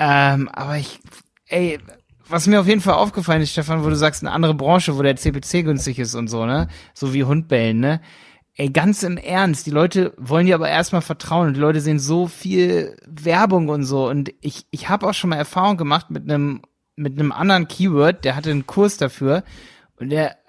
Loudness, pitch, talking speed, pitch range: -19 LUFS, 155 Hz, 210 wpm, 140-175 Hz